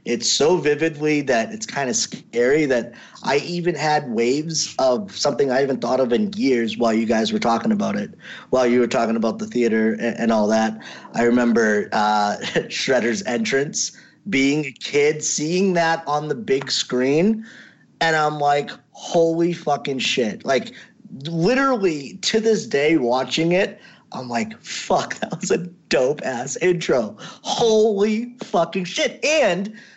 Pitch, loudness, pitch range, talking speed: 150 Hz, -20 LUFS, 120-180 Hz, 155 wpm